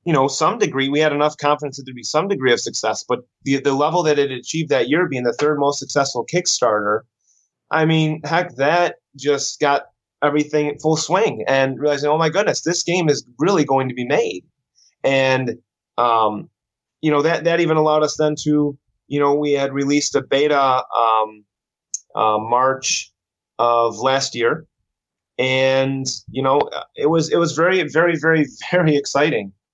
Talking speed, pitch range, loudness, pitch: 180 wpm, 130-155 Hz, -18 LUFS, 145 Hz